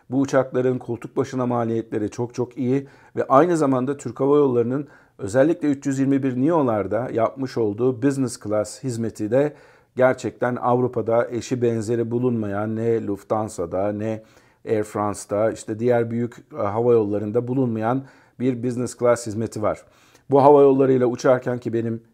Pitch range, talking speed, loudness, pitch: 115-130 Hz, 135 wpm, -22 LUFS, 120 Hz